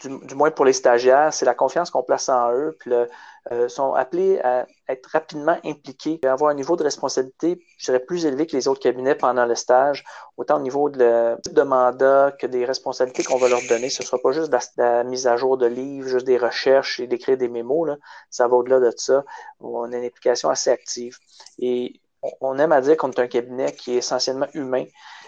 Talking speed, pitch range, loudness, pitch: 235 wpm, 125-150 Hz, -21 LUFS, 130 Hz